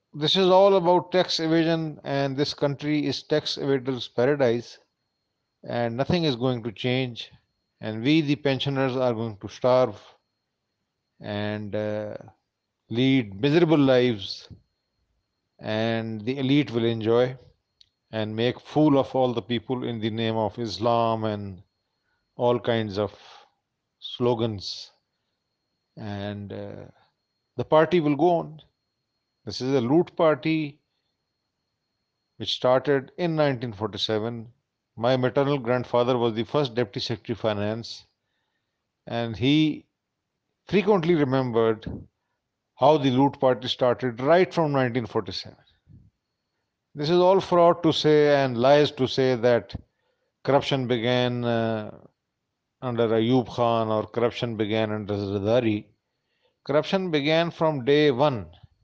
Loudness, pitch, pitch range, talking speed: -24 LUFS, 125 Hz, 110-145 Hz, 120 wpm